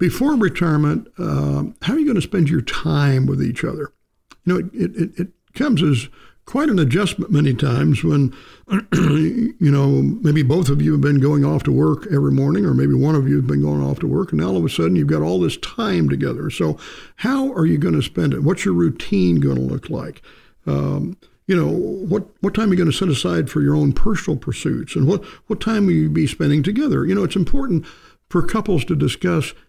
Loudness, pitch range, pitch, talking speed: -18 LUFS, 135-185 Hz, 155 Hz, 230 wpm